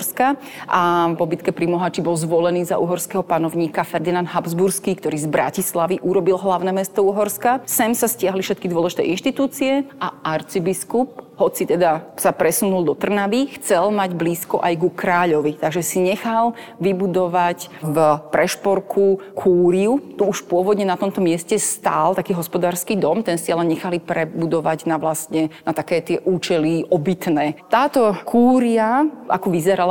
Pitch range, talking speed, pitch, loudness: 170-200 Hz, 140 wpm, 180 Hz, -19 LUFS